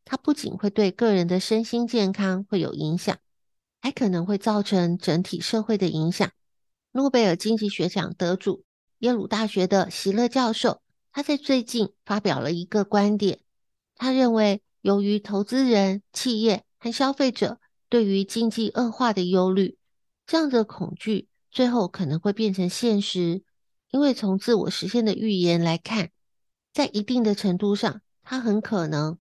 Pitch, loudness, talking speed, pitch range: 205 Hz, -24 LUFS, 240 characters per minute, 190-235 Hz